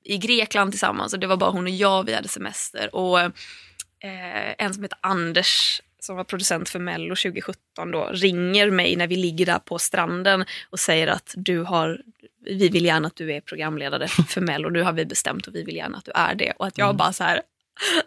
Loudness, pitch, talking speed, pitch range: -22 LUFS, 185 Hz, 220 wpm, 175-195 Hz